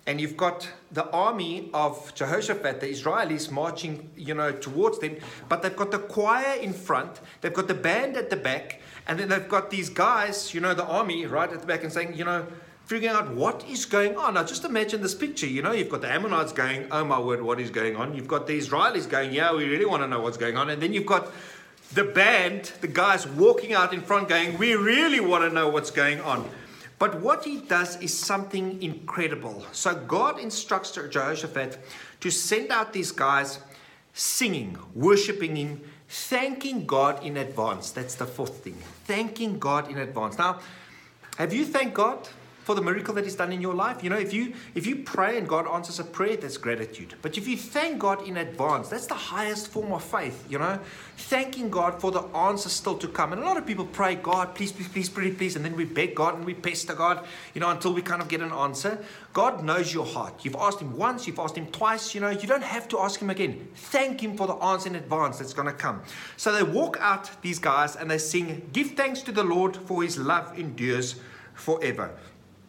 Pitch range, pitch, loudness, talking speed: 155-205 Hz, 175 Hz, -26 LUFS, 220 wpm